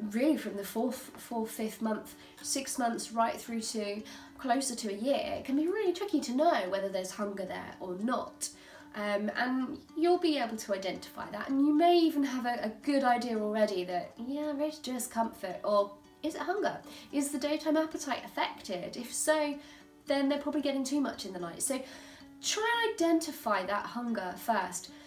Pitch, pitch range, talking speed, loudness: 260 Hz, 220-300 Hz, 190 wpm, -32 LUFS